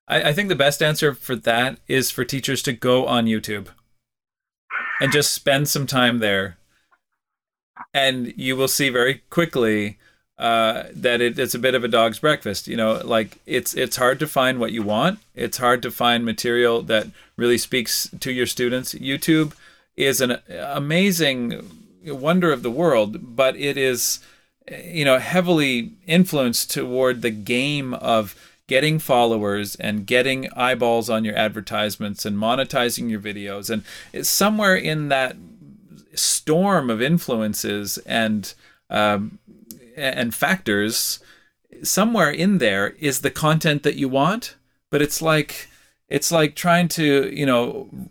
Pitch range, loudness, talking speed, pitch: 115-150 Hz, -20 LUFS, 150 wpm, 130 Hz